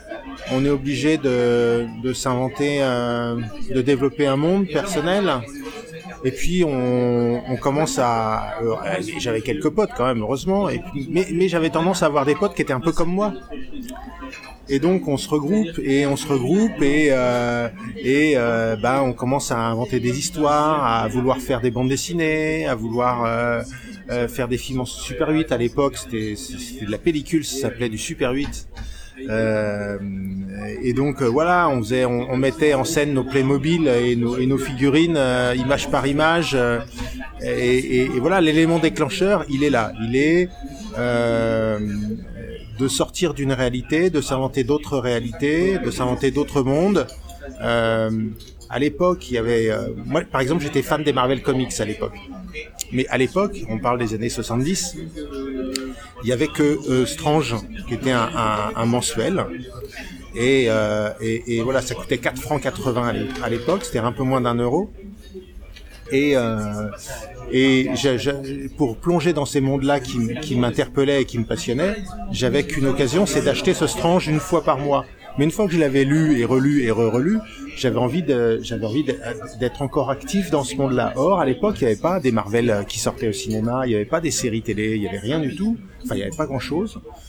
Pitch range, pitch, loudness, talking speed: 120-150 Hz, 130 Hz, -21 LUFS, 190 wpm